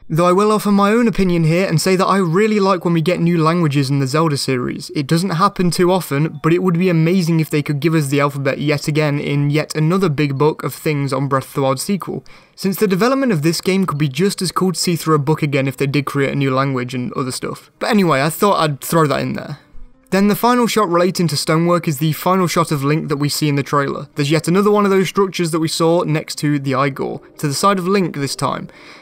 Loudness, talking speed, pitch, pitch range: -16 LUFS, 270 wpm, 160 Hz, 145-185 Hz